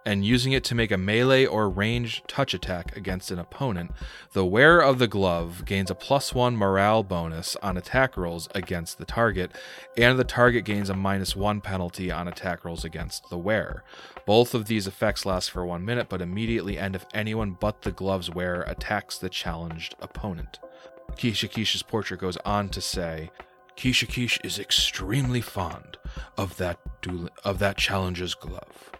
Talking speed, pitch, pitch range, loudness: 170 wpm, 95 Hz, 90-115 Hz, -26 LUFS